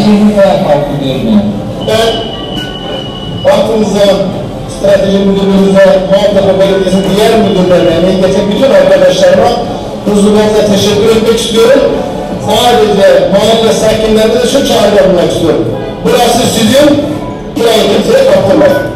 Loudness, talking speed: -7 LUFS, 90 wpm